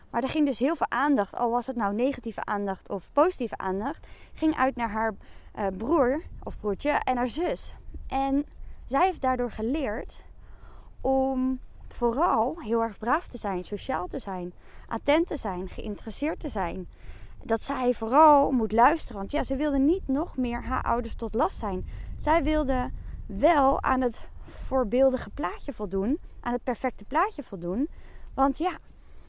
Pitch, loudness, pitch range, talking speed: 255 Hz, -27 LUFS, 225-285 Hz, 160 wpm